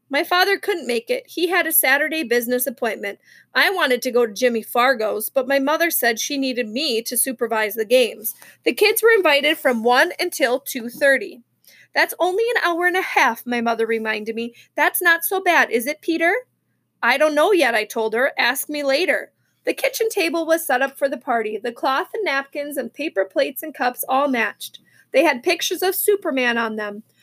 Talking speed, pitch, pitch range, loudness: 205 wpm, 275 Hz, 240-345 Hz, -19 LUFS